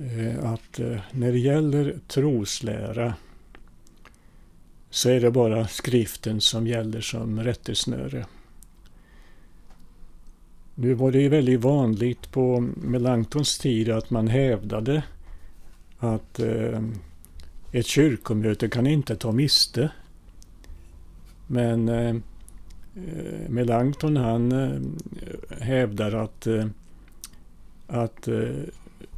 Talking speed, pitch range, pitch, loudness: 75 wpm, 105-125 Hz, 115 Hz, -24 LUFS